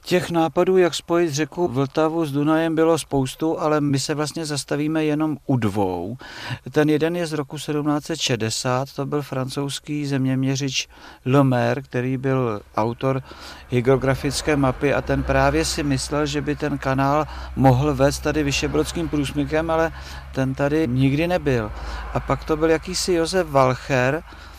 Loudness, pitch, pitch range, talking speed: -21 LUFS, 145 Hz, 130-155 Hz, 145 wpm